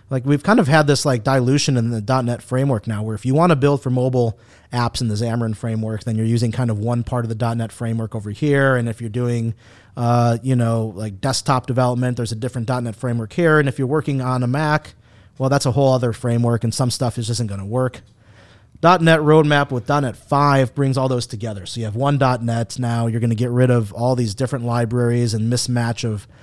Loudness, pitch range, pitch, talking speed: -19 LUFS, 115-130 Hz, 120 Hz, 240 wpm